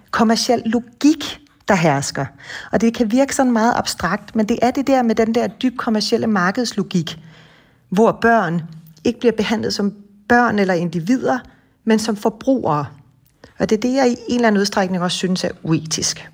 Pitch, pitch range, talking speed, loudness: 220 Hz, 175-235 Hz, 175 wpm, -18 LUFS